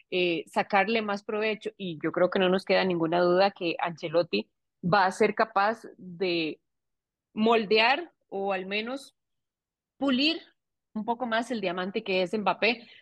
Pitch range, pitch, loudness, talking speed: 180-225 Hz, 200 Hz, -27 LUFS, 150 wpm